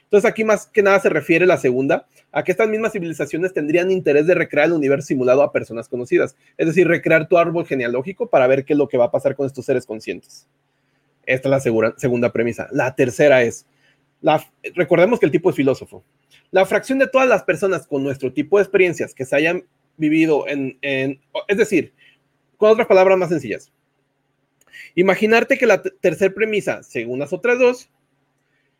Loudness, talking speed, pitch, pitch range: -18 LUFS, 195 wpm, 155 Hz, 140-190 Hz